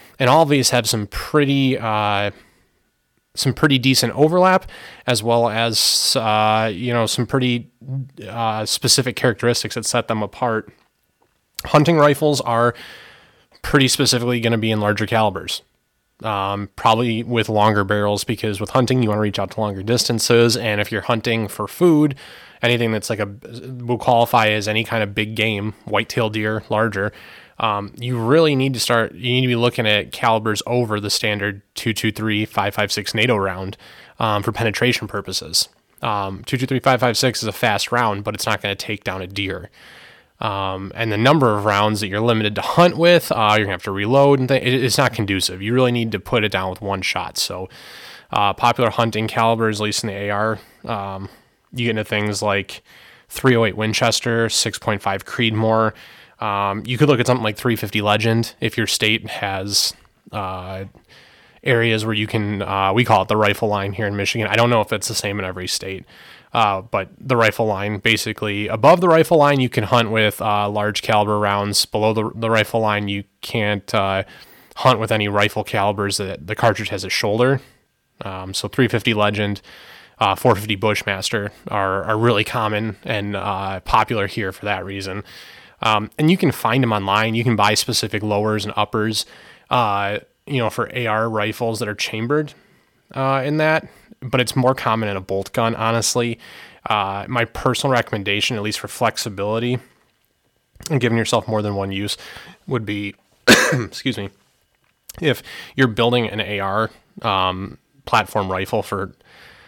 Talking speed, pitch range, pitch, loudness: 180 wpm, 105-120 Hz, 110 Hz, -19 LUFS